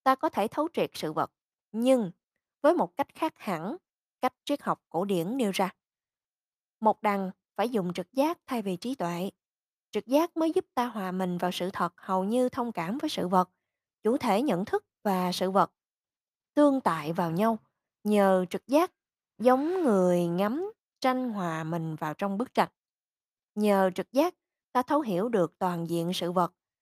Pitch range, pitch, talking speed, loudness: 180-265 Hz, 205 Hz, 185 wpm, -29 LUFS